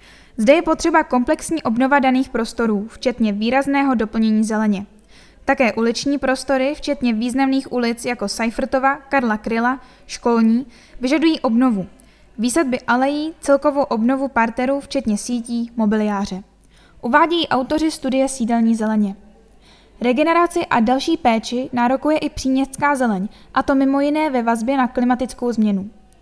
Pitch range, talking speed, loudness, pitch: 230-275 Hz, 125 wpm, -18 LUFS, 250 Hz